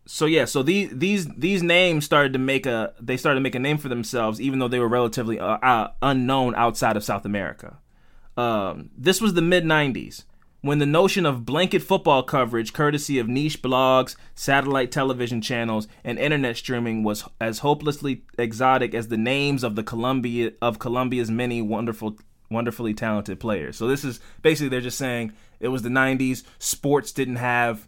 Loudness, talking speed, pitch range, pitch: -23 LUFS, 185 wpm, 115-140 Hz, 125 Hz